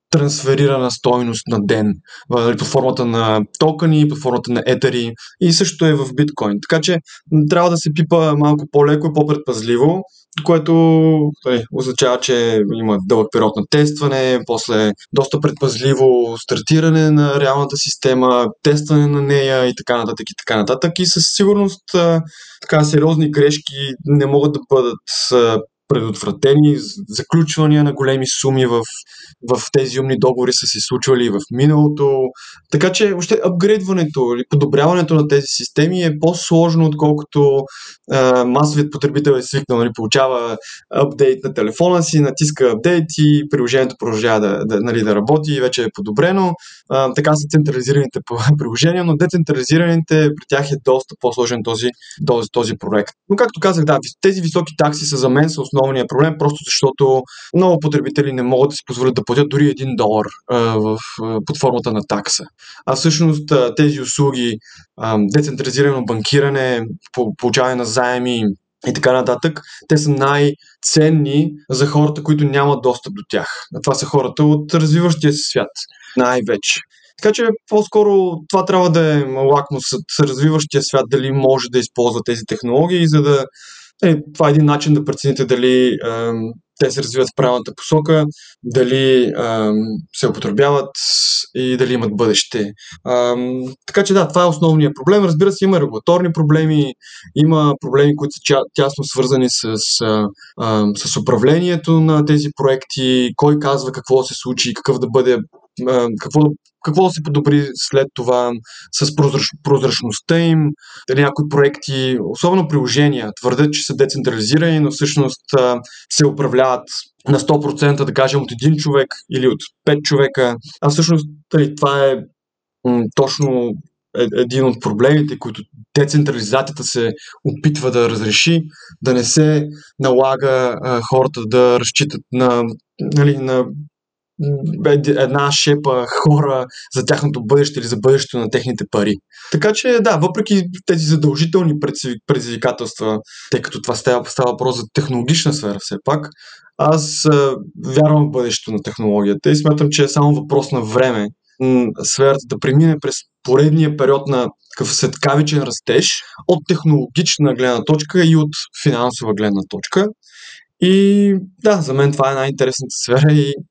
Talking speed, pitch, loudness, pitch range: 145 wpm, 140 Hz, -15 LUFS, 125-155 Hz